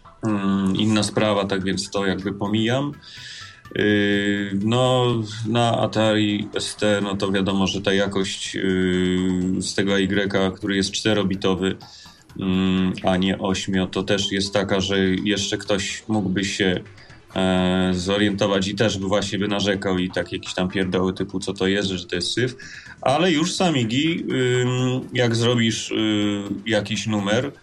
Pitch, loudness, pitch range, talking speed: 100 Hz, -22 LUFS, 95-110 Hz, 135 wpm